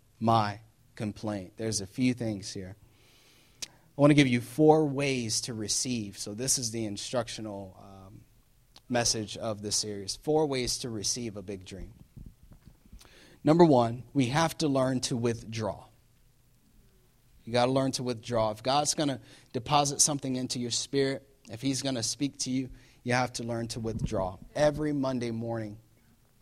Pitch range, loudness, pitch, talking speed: 110-135 Hz, -29 LUFS, 120 Hz, 165 wpm